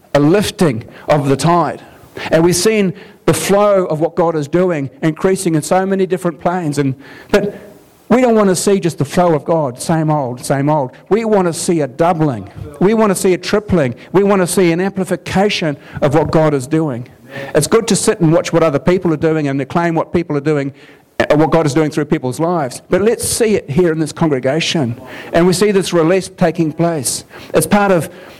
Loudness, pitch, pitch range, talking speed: -14 LUFS, 165 Hz, 150-185 Hz, 220 wpm